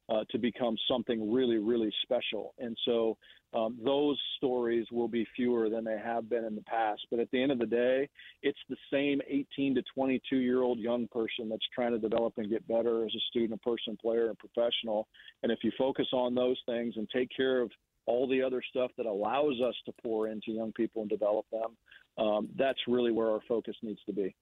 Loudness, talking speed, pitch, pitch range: -32 LUFS, 220 wpm, 115 Hz, 110-125 Hz